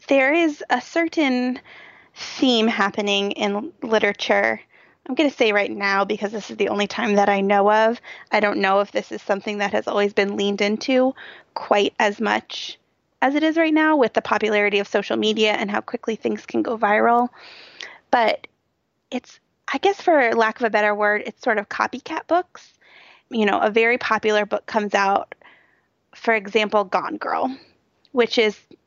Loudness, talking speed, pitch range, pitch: -20 LUFS, 180 wpm, 205-255 Hz, 220 Hz